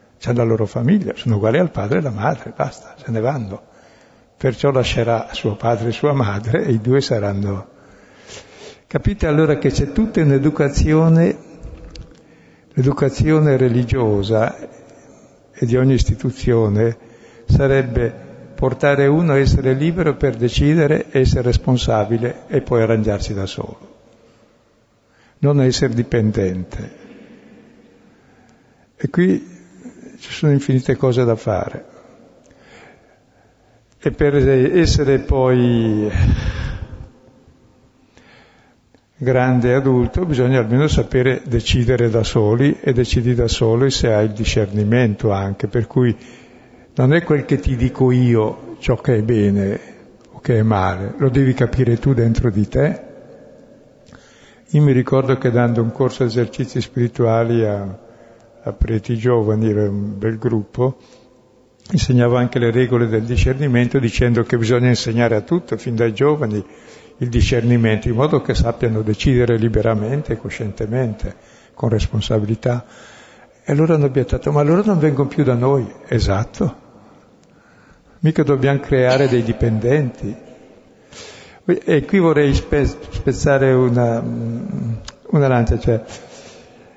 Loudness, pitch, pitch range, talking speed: -17 LUFS, 120 Hz, 115-135 Hz, 125 wpm